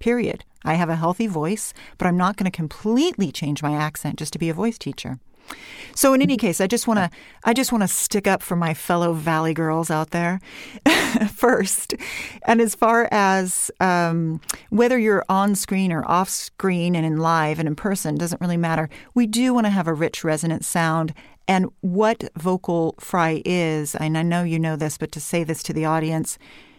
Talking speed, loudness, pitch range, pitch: 205 wpm, -21 LUFS, 160-215 Hz, 175 Hz